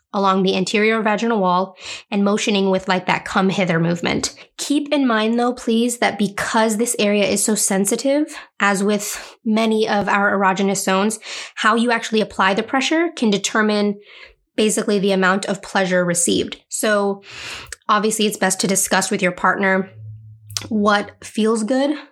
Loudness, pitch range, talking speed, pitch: -18 LUFS, 190-225 Hz, 155 wpm, 205 Hz